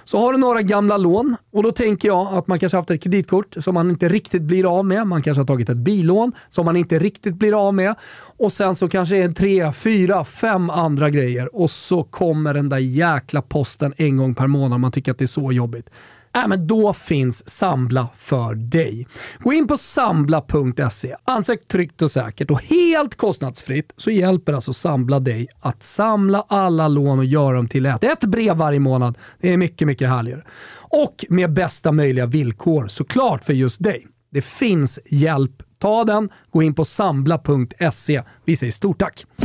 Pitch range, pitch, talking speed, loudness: 135-195 Hz, 165 Hz, 195 wpm, -19 LUFS